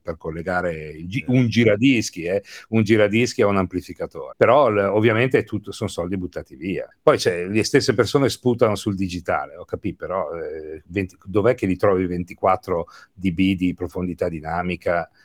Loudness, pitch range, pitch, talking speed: -21 LUFS, 90-115 Hz, 100 Hz, 140 wpm